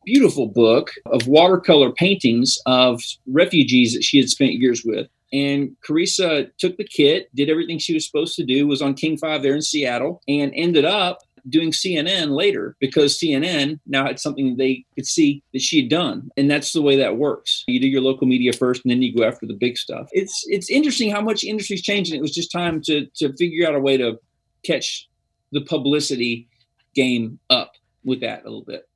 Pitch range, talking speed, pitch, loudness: 130-170 Hz, 205 wpm, 145 Hz, -19 LUFS